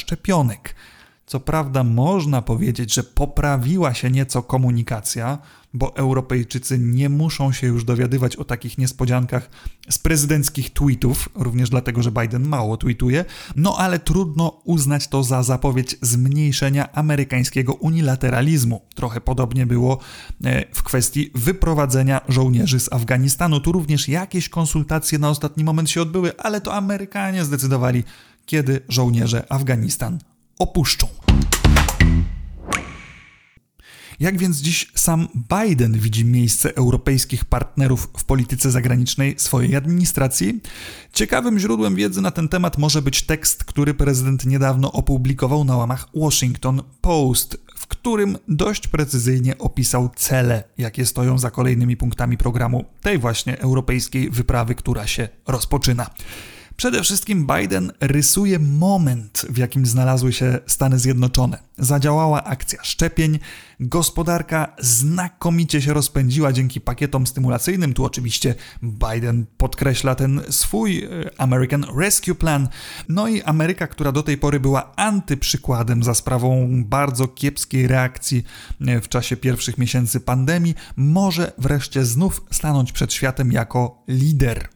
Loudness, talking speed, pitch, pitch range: -19 LUFS, 120 wpm, 130 Hz, 125-150 Hz